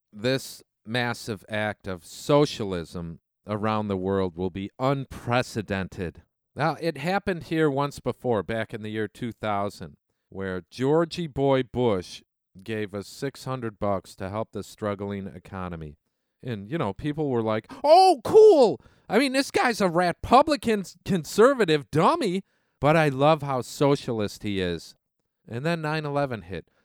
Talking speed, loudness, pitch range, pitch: 145 wpm, -25 LUFS, 100-155 Hz, 120 Hz